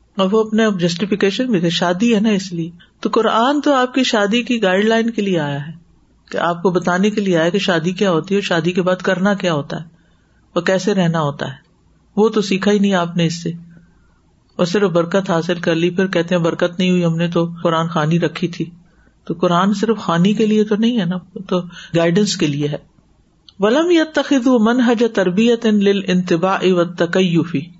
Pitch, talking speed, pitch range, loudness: 185 Hz, 205 wpm, 170-210 Hz, -16 LUFS